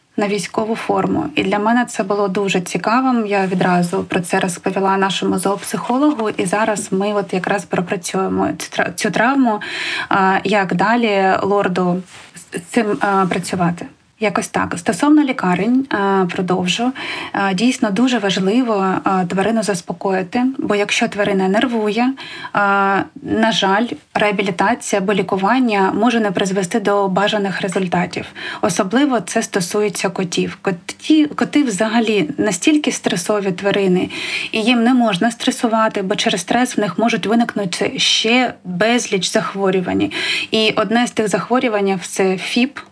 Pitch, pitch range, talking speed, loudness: 210 Hz, 195-235 Hz, 125 wpm, -17 LUFS